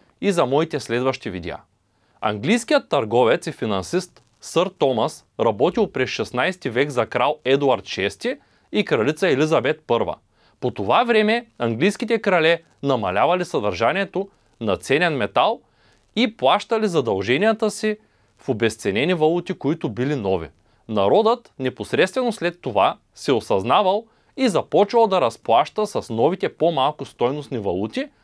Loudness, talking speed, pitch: -21 LUFS, 125 wpm, 165 Hz